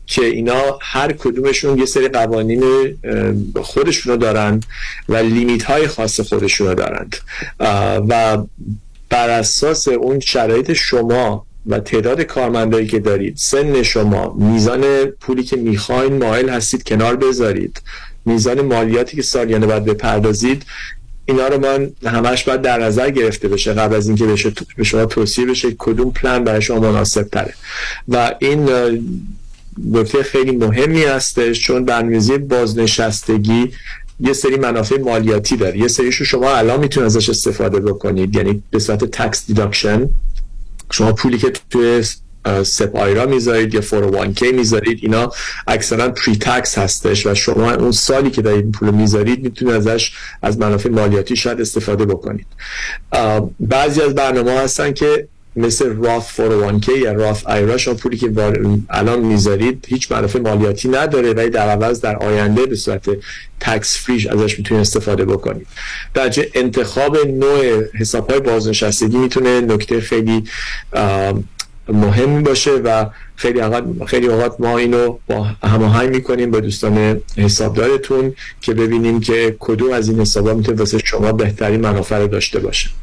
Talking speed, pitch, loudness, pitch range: 140 wpm, 115 Hz, -15 LUFS, 105-125 Hz